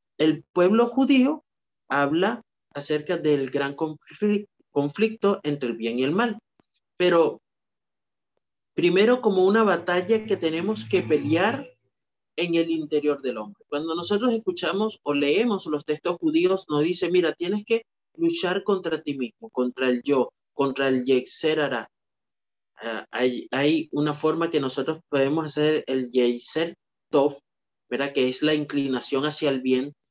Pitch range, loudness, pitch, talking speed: 140-190 Hz, -24 LUFS, 155 Hz, 140 wpm